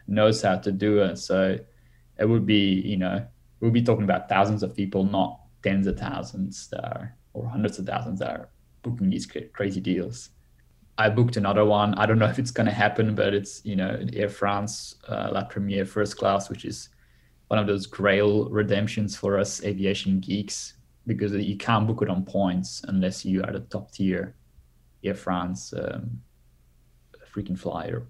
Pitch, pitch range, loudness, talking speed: 100 Hz, 90-105 Hz, -26 LUFS, 185 wpm